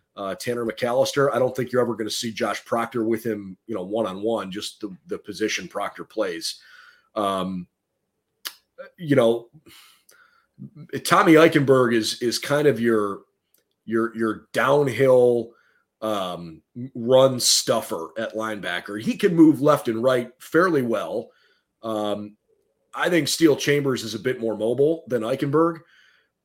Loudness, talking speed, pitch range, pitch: -22 LUFS, 145 wpm, 110-140 Hz, 120 Hz